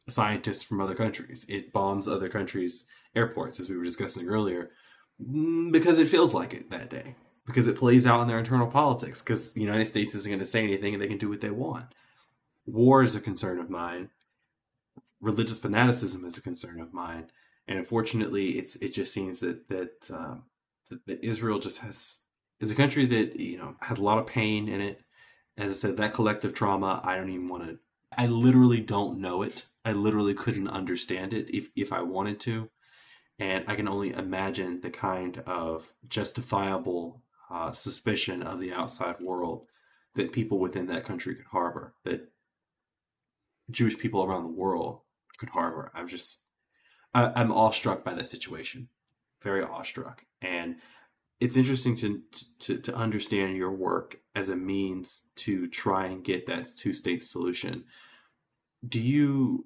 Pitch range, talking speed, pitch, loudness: 95-120 Hz, 175 wpm, 105 Hz, -29 LUFS